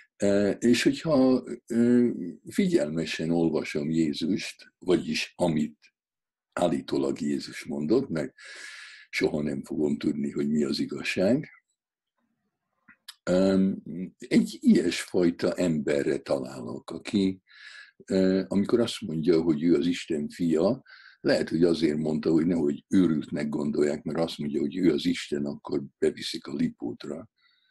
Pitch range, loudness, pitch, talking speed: 75-115 Hz, -27 LUFS, 90 Hz, 110 wpm